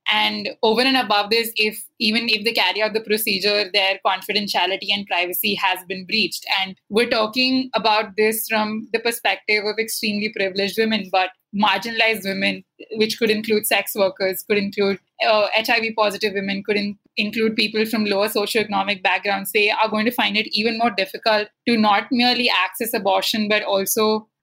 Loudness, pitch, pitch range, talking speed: -19 LUFS, 215 Hz, 200-225 Hz, 170 wpm